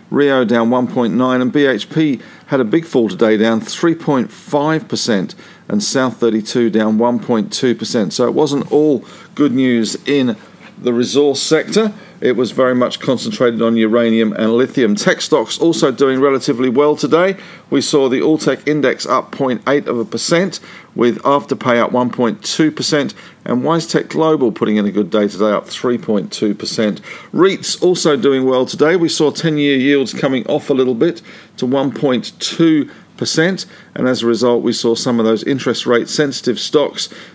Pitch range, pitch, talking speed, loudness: 120-150 Hz, 130 Hz, 160 wpm, -15 LUFS